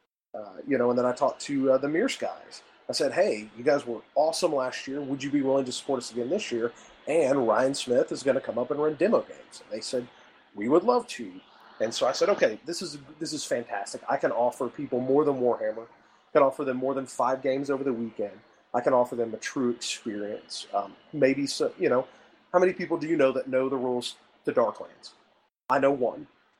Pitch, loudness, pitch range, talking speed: 135 Hz, -27 LUFS, 125-150 Hz, 235 wpm